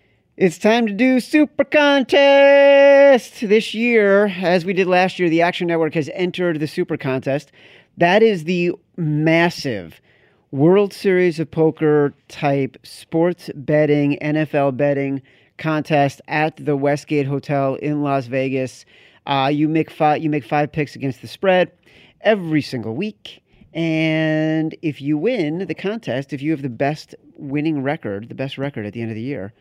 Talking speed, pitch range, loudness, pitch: 160 wpm, 140-180 Hz, -18 LUFS, 155 Hz